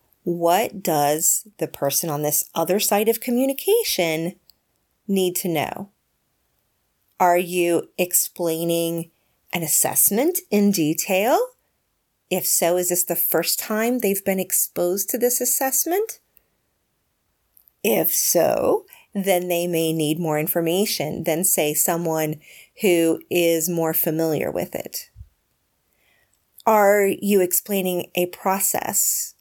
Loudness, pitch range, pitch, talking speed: -20 LUFS, 165-200 Hz, 175 Hz, 110 wpm